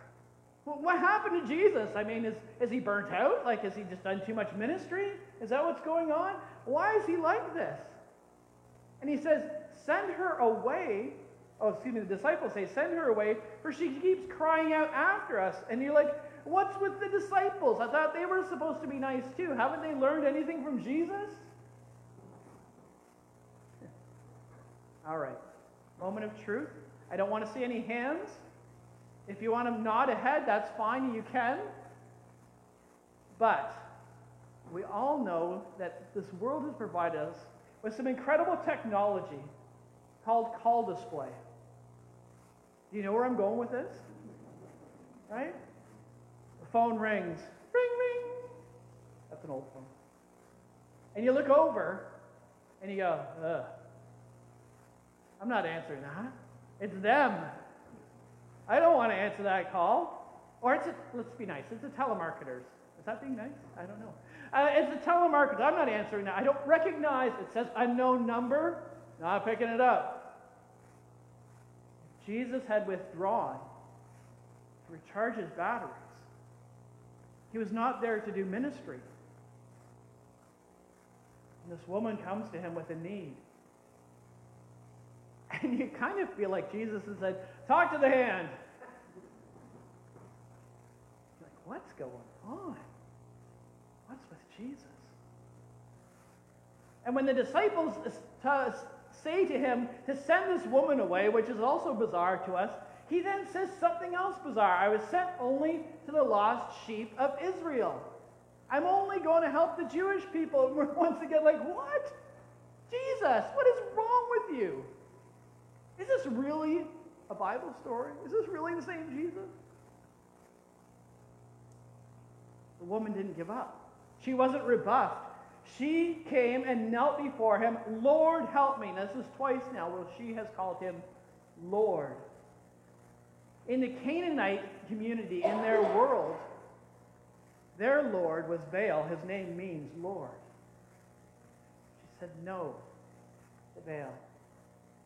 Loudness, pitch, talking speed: -32 LUFS, 210 Hz, 145 wpm